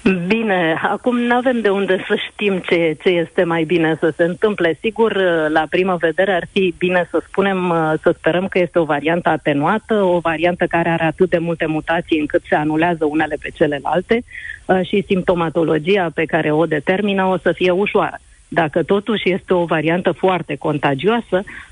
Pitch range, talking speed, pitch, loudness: 165-195 Hz, 175 wpm, 175 Hz, -17 LUFS